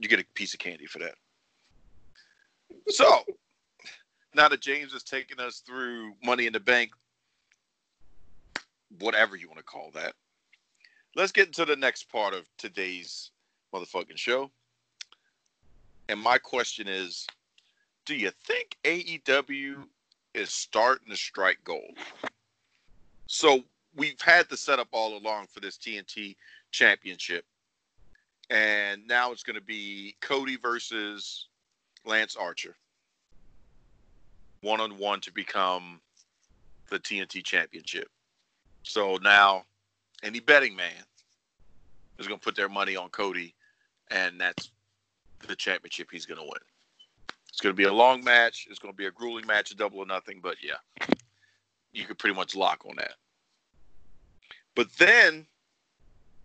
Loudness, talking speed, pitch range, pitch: -26 LUFS, 135 wpm, 100-140 Hz, 115 Hz